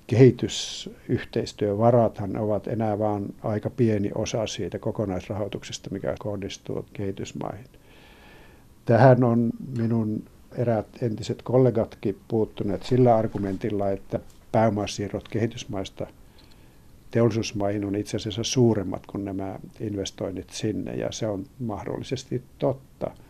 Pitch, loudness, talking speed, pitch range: 110 Hz, -26 LUFS, 100 wpm, 100-115 Hz